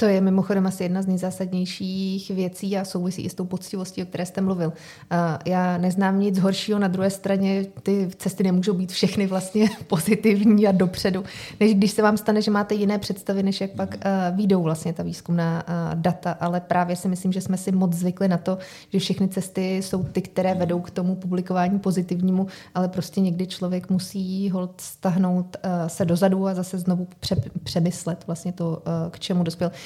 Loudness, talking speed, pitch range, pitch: -23 LUFS, 185 wpm, 180-195 Hz, 185 Hz